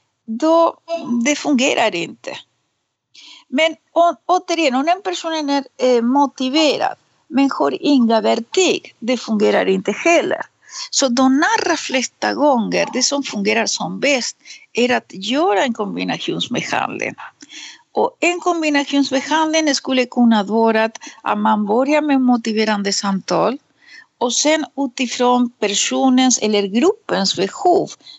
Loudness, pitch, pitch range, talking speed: -17 LUFS, 270 Hz, 230-315 Hz, 115 wpm